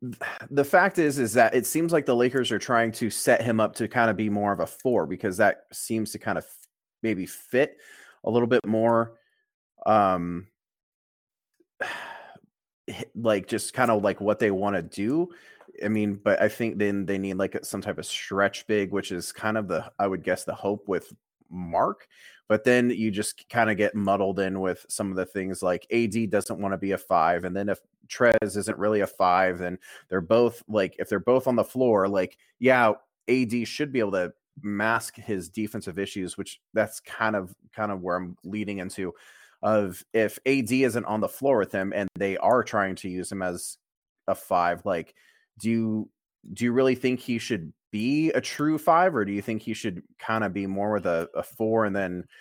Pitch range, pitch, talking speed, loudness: 95-115 Hz, 105 Hz, 210 wpm, -26 LUFS